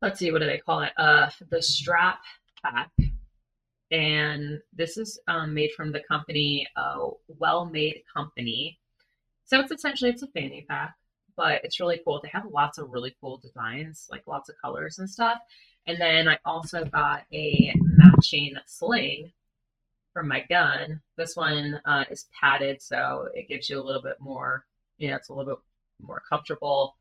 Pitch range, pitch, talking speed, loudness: 140-175 Hz, 155 Hz, 180 wpm, -24 LUFS